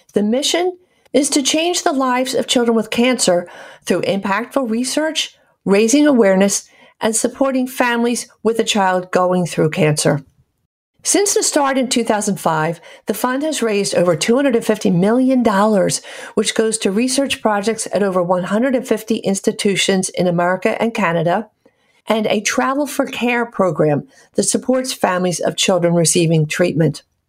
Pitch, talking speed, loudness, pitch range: 225 Hz, 140 wpm, -16 LUFS, 185-255 Hz